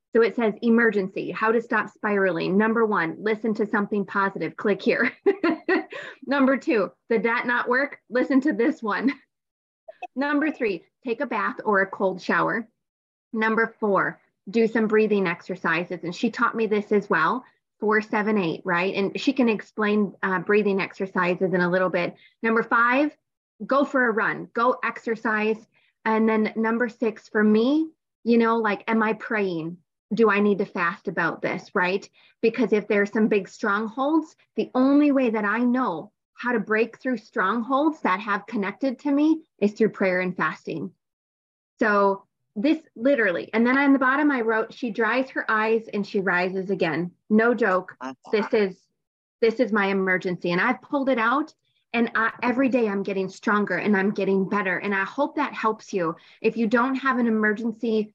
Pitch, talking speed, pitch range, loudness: 220 Hz, 175 wpm, 200-245 Hz, -23 LUFS